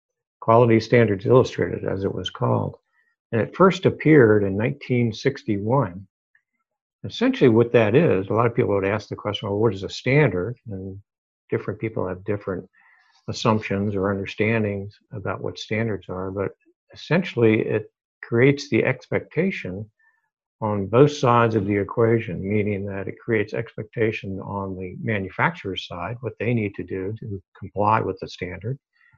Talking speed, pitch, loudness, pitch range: 150 wpm, 110 Hz, -22 LUFS, 100-125 Hz